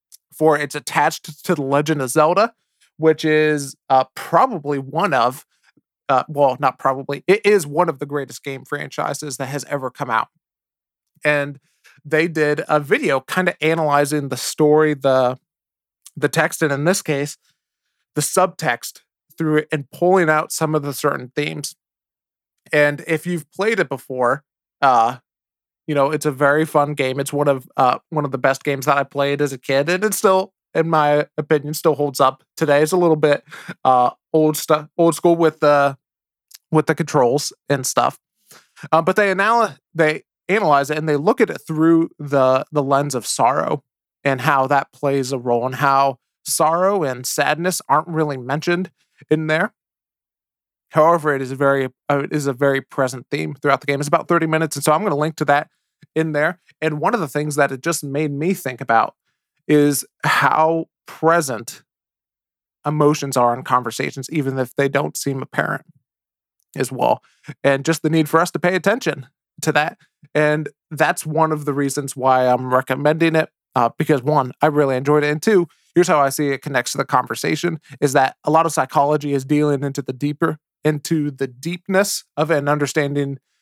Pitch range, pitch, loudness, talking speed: 140-160 Hz, 150 Hz, -19 LUFS, 185 wpm